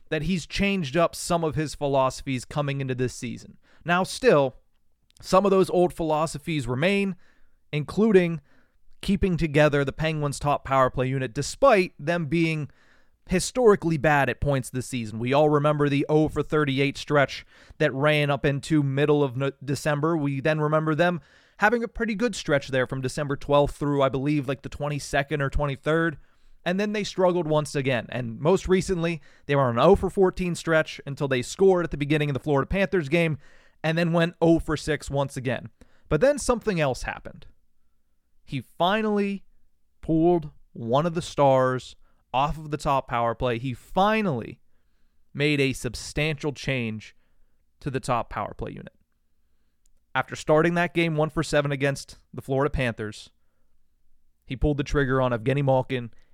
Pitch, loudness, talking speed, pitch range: 145 Hz, -24 LUFS, 170 wpm, 130-165 Hz